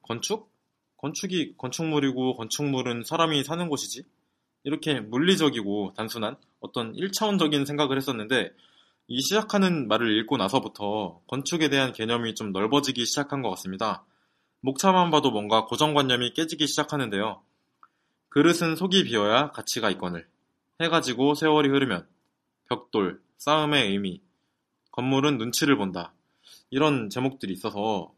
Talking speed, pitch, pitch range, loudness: 315 characters per minute, 135 Hz, 110-150 Hz, -25 LUFS